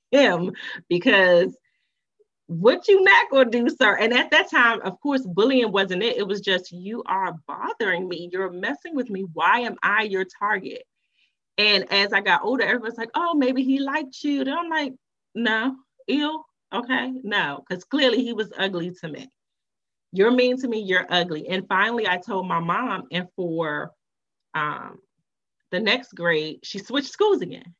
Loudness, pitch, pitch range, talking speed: -22 LUFS, 230 Hz, 185-270 Hz, 175 wpm